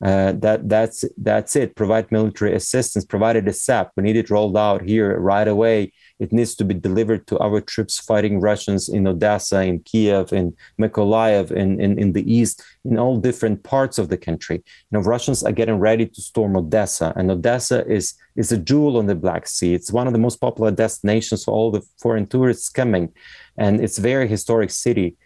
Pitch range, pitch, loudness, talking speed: 100-115 Hz, 105 Hz, -19 LUFS, 200 wpm